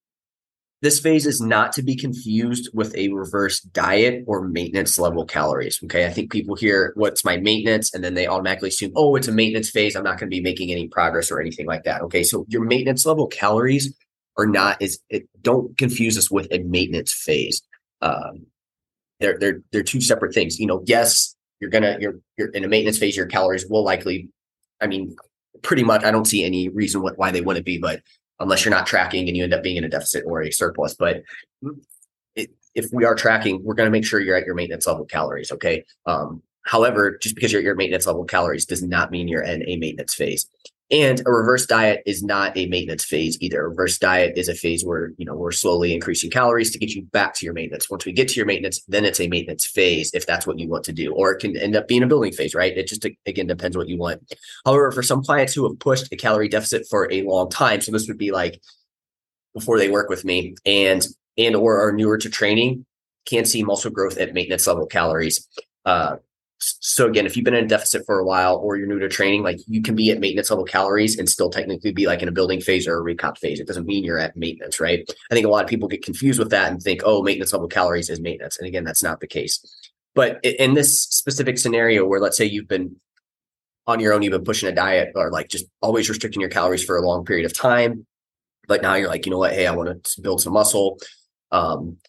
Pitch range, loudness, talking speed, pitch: 90-115 Hz, -20 LUFS, 240 wpm, 105 Hz